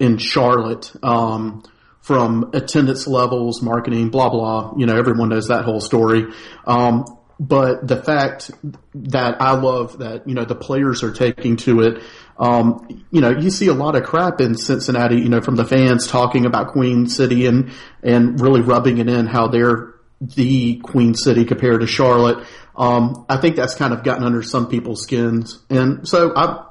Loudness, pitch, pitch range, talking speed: -16 LUFS, 120 Hz, 115-130 Hz, 180 wpm